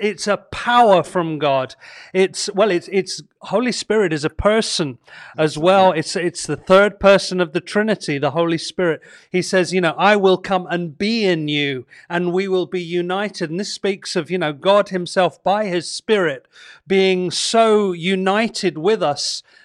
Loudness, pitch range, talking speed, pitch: -18 LUFS, 170-200 Hz, 180 wpm, 185 Hz